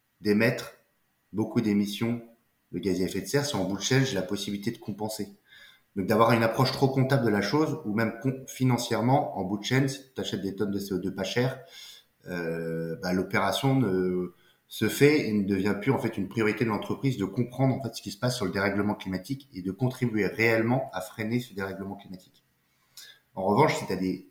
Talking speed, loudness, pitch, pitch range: 215 wpm, -28 LUFS, 110 Hz, 95-125 Hz